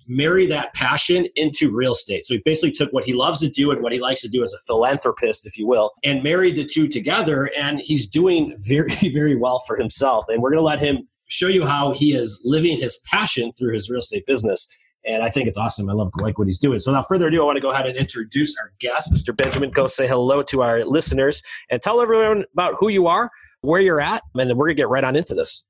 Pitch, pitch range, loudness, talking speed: 140 Hz, 125-170 Hz, -19 LUFS, 260 wpm